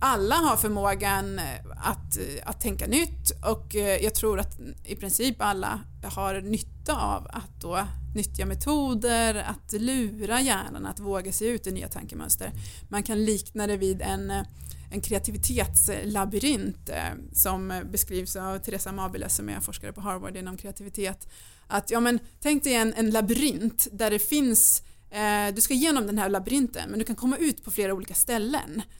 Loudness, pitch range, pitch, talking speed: -26 LUFS, 190-230 Hz, 205 Hz, 160 wpm